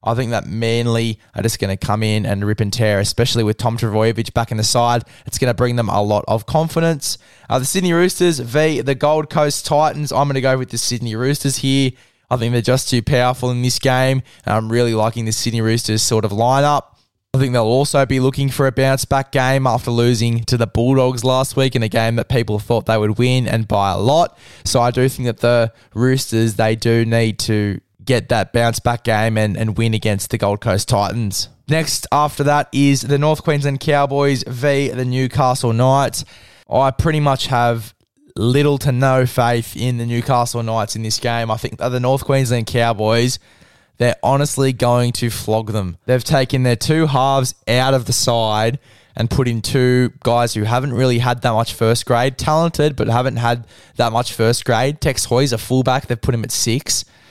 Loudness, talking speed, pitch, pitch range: -17 LUFS, 210 wpm, 120 Hz, 115-135 Hz